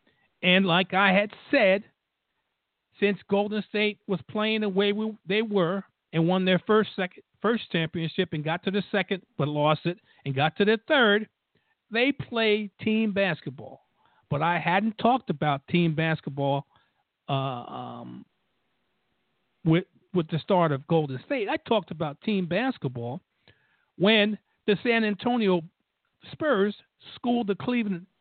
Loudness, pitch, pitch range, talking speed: -26 LUFS, 190 Hz, 165-215 Hz, 145 wpm